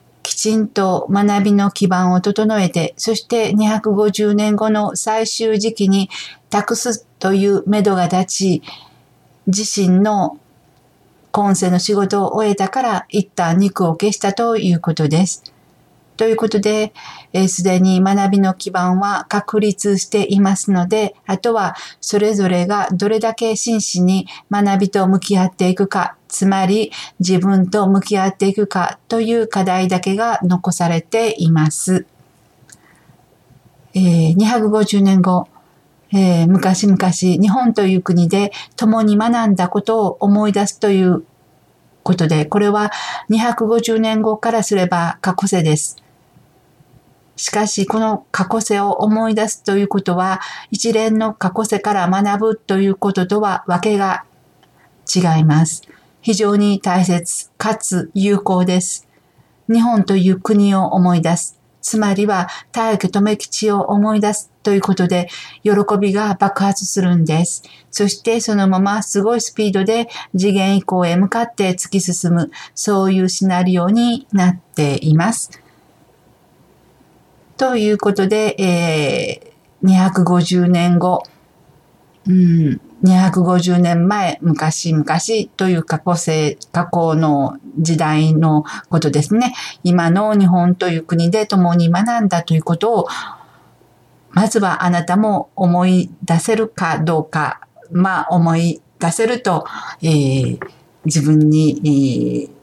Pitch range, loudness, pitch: 175-210 Hz, -16 LUFS, 190 Hz